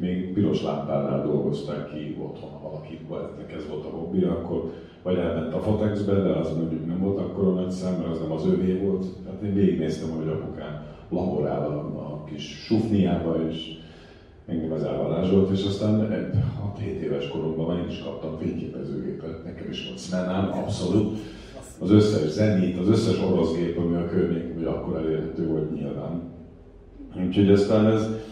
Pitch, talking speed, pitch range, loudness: 85 Hz, 165 wpm, 80-95 Hz, -26 LUFS